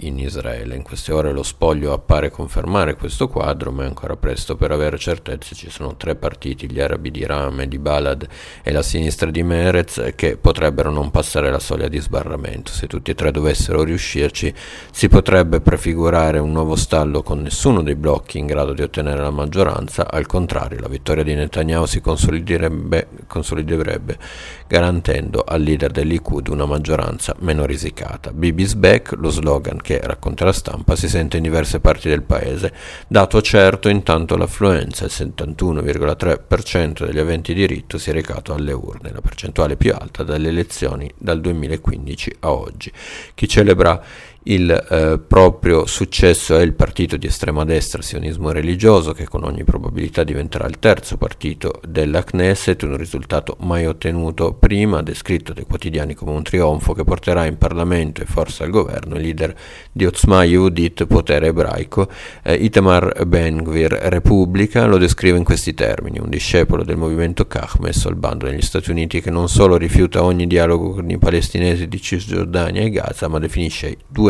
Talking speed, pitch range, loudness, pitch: 165 wpm, 75-90 Hz, -17 LUFS, 80 Hz